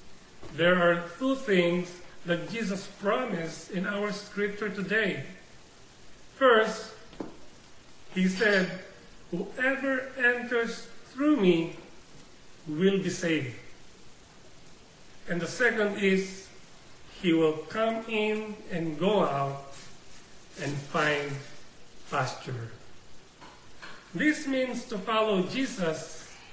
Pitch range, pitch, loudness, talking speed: 165-220 Hz, 190 Hz, -28 LUFS, 90 wpm